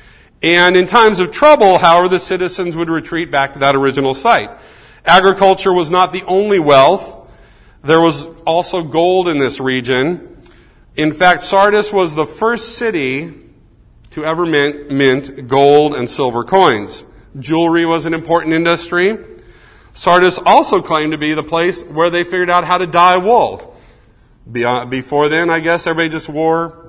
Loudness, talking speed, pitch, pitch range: -13 LUFS, 155 wpm, 165 Hz, 150-180 Hz